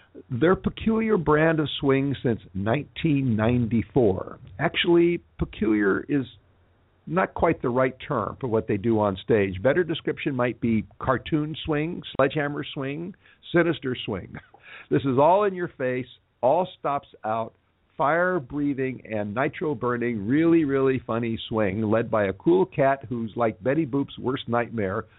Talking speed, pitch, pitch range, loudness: 145 wpm, 130 Hz, 110-155 Hz, -25 LUFS